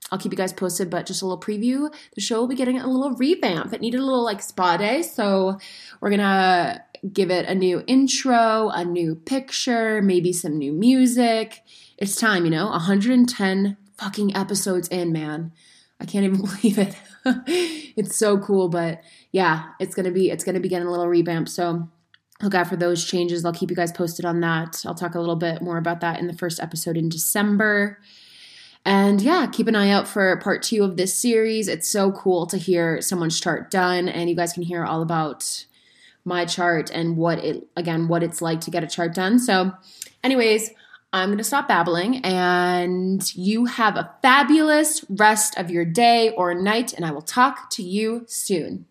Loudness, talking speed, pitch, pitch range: -21 LUFS, 200 wpm, 190 Hz, 175-220 Hz